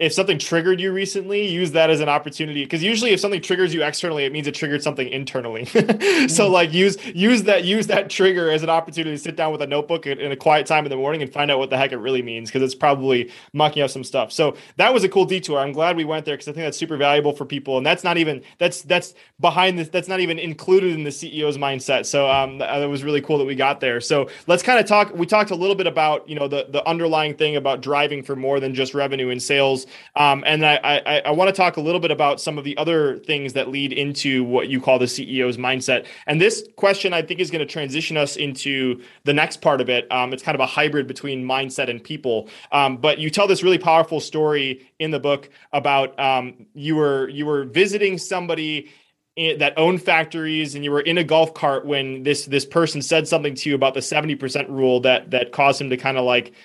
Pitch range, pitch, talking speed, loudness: 135-165 Hz, 150 Hz, 250 wpm, -20 LUFS